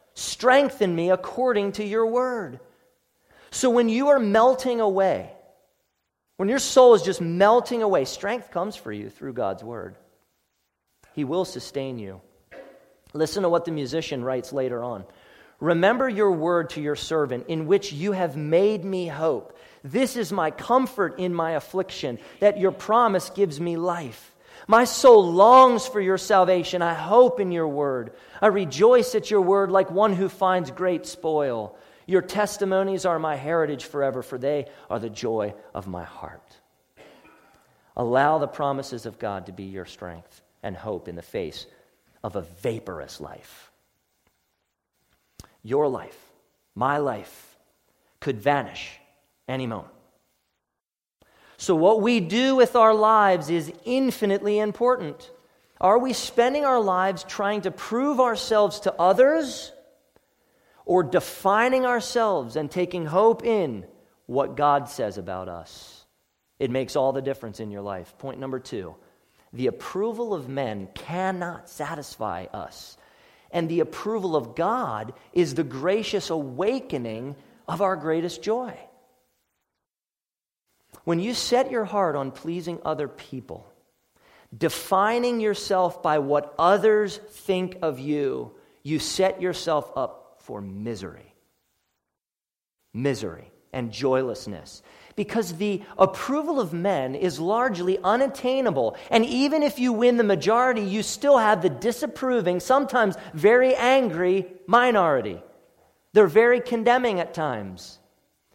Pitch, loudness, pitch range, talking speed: 180 Hz, -23 LUFS, 140-220 Hz, 135 wpm